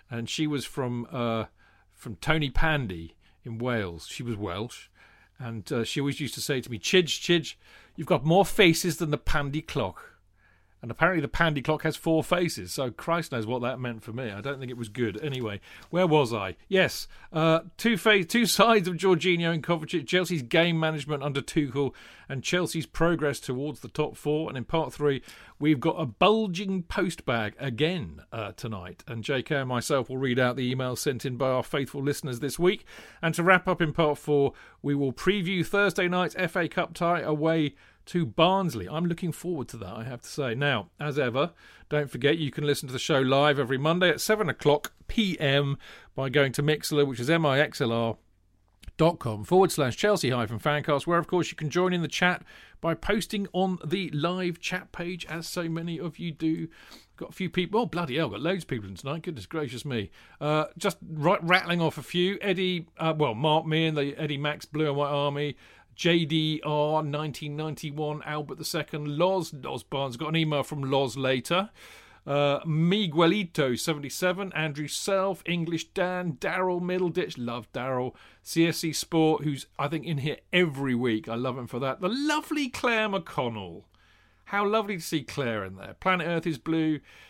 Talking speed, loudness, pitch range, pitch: 195 wpm, -27 LUFS, 130-175 Hz, 155 Hz